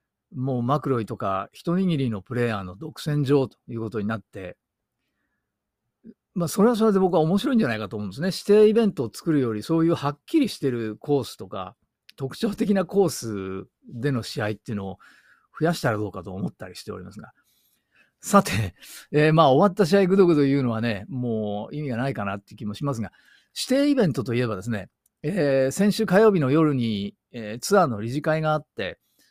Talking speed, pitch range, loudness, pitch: 395 characters per minute, 110-175 Hz, -23 LUFS, 140 Hz